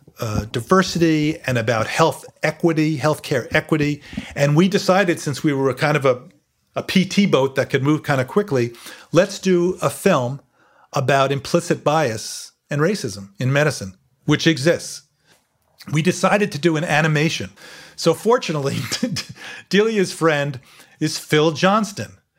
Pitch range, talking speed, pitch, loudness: 140-170 Hz, 140 wpm, 155 Hz, -19 LUFS